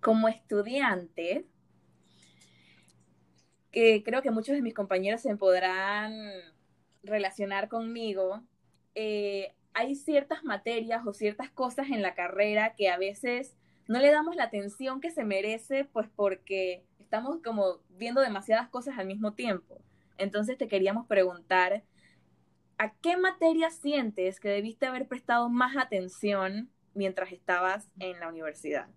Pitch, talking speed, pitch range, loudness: 205 Hz, 130 wpm, 185-245 Hz, -30 LUFS